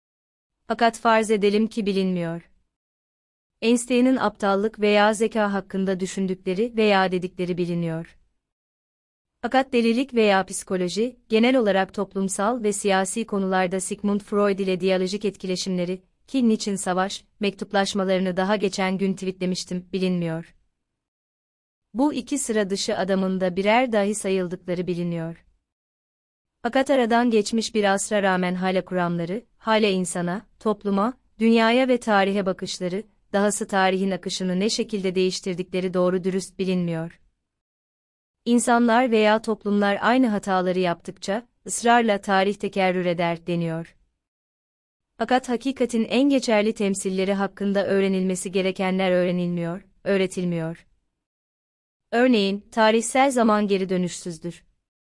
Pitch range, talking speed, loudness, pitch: 185-220 Hz, 105 wpm, -23 LUFS, 195 Hz